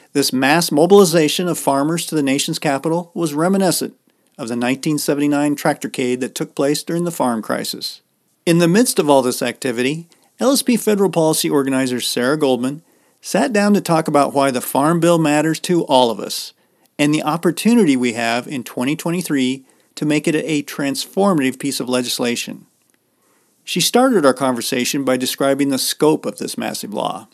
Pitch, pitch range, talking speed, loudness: 150 Hz, 135-170 Hz, 165 wpm, -17 LUFS